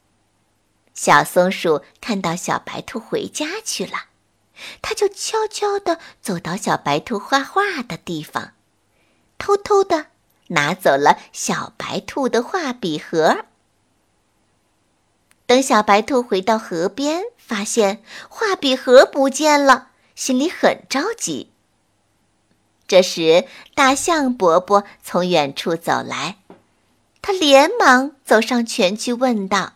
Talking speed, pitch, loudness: 165 characters per minute, 230 Hz, -18 LUFS